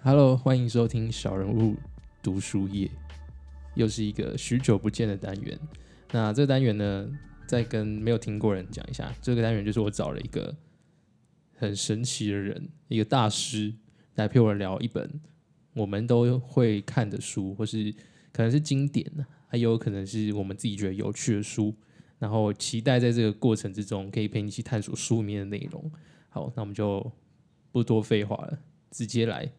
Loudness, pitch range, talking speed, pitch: -28 LUFS, 105-135 Hz, 270 characters per minute, 115 Hz